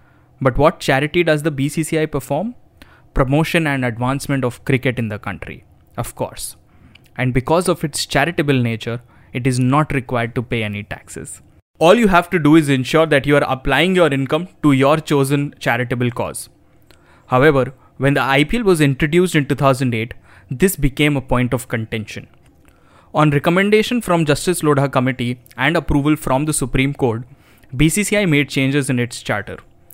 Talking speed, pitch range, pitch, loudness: 160 wpm, 125-155 Hz, 140 Hz, -17 LUFS